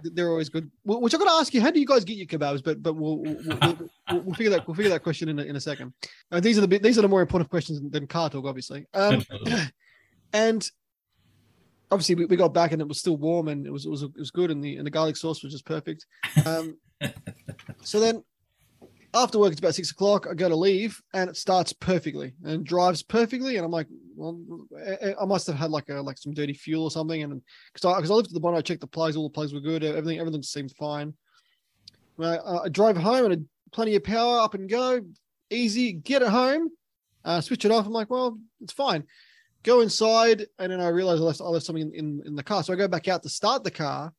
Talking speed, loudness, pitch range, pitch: 250 wpm, -25 LUFS, 155-215 Hz, 175 Hz